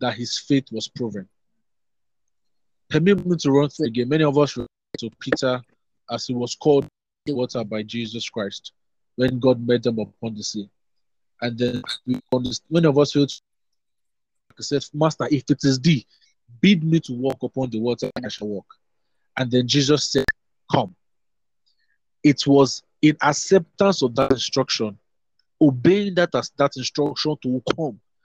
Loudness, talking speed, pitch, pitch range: -21 LUFS, 160 wpm, 130 Hz, 115-145 Hz